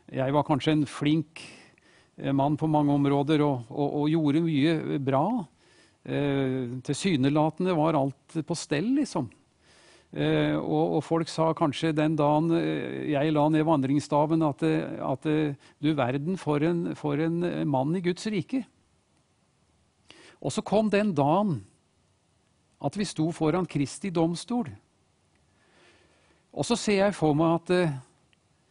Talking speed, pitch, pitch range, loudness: 135 wpm, 155 Hz, 140-165 Hz, -27 LUFS